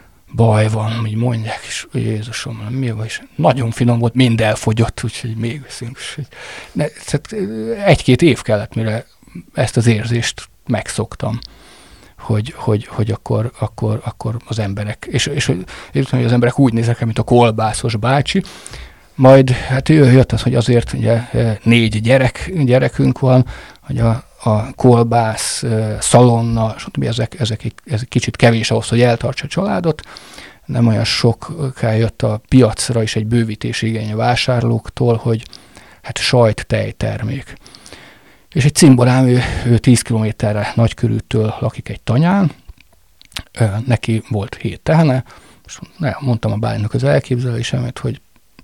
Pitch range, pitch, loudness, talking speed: 110-125 Hz, 115 Hz, -16 LUFS, 135 wpm